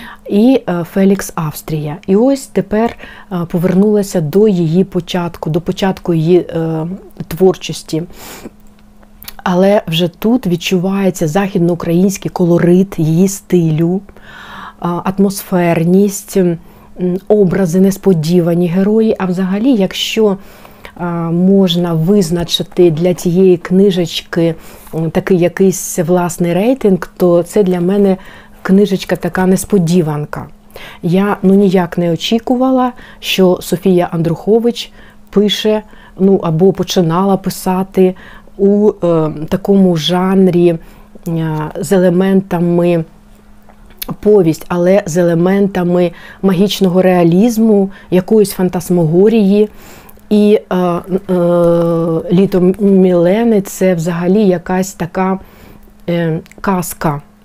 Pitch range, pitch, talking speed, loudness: 175-195 Hz, 185 Hz, 90 wpm, -12 LUFS